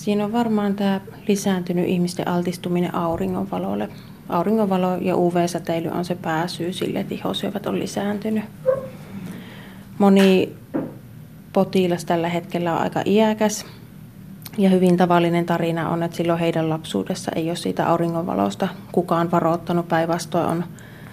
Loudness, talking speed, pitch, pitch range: -21 LUFS, 120 wpm, 175 Hz, 170-195 Hz